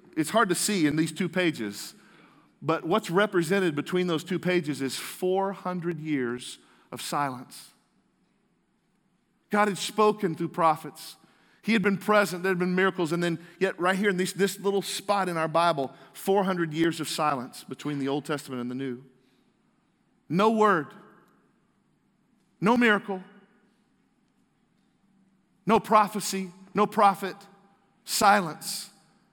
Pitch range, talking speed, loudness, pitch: 160-200 Hz, 135 wpm, -26 LUFS, 185 Hz